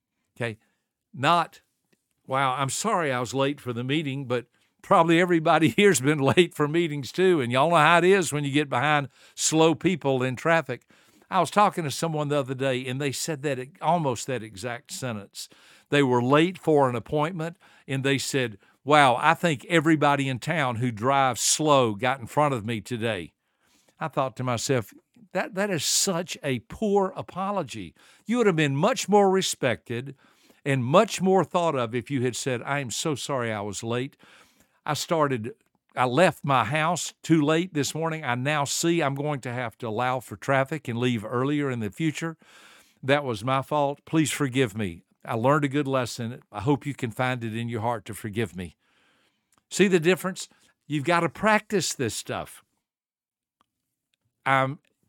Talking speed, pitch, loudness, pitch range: 185 wpm, 140 Hz, -25 LUFS, 125-165 Hz